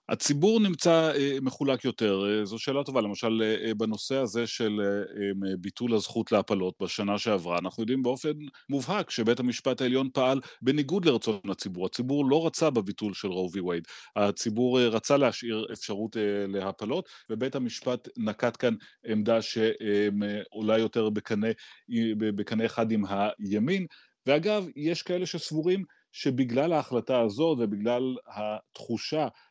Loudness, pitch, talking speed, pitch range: -28 LUFS, 115 Hz, 120 wpm, 105-140 Hz